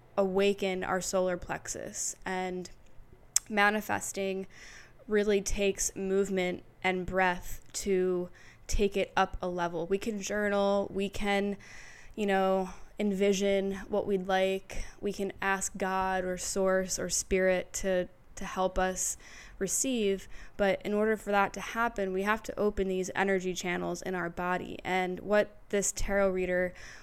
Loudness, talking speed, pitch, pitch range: -31 LUFS, 140 wpm, 195 Hz, 185-200 Hz